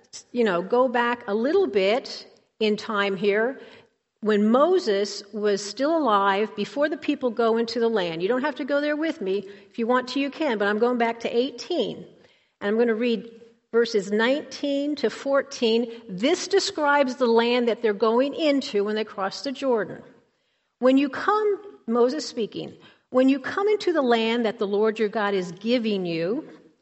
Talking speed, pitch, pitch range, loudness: 185 wpm, 235 Hz, 210-275 Hz, -24 LUFS